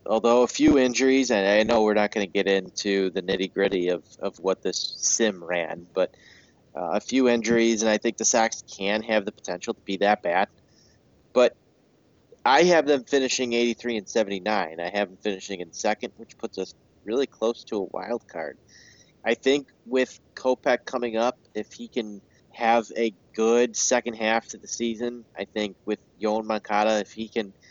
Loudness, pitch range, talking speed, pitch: -24 LUFS, 100-120 Hz, 195 wpm, 110 Hz